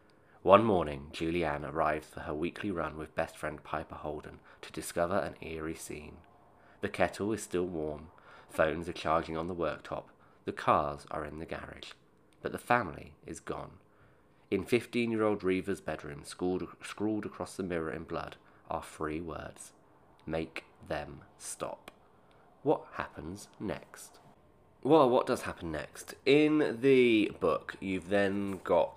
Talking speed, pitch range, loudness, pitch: 150 wpm, 75-100 Hz, -33 LUFS, 85 Hz